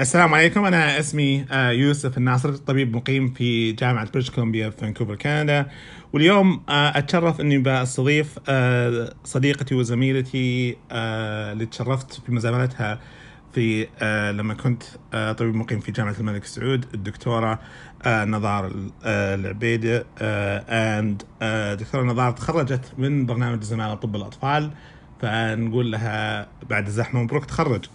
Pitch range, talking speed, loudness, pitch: 110-135 Hz, 110 wpm, -22 LUFS, 125 Hz